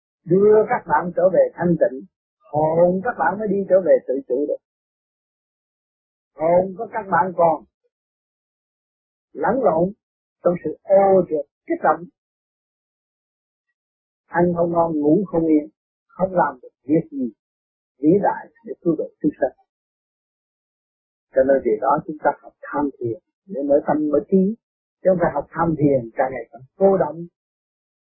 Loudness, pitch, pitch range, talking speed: -20 LUFS, 175 Hz, 155-215 Hz, 155 wpm